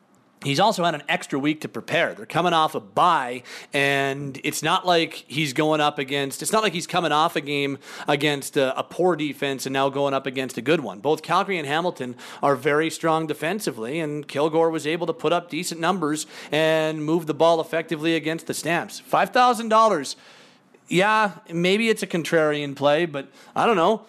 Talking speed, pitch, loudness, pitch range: 195 wpm, 160 Hz, -22 LUFS, 145-175 Hz